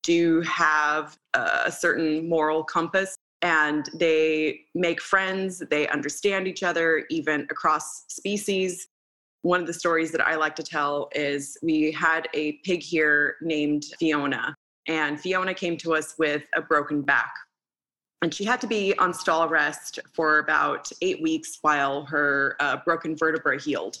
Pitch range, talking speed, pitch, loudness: 150-180 Hz, 155 wpm, 160 Hz, -24 LUFS